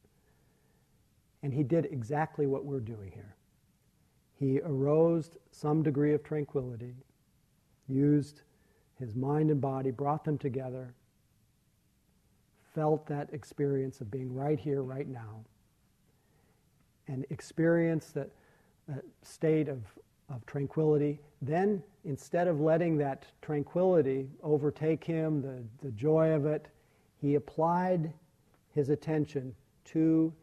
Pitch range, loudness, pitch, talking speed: 135-155 Hz, -32 LUFS, 145 Hz, 110 wpm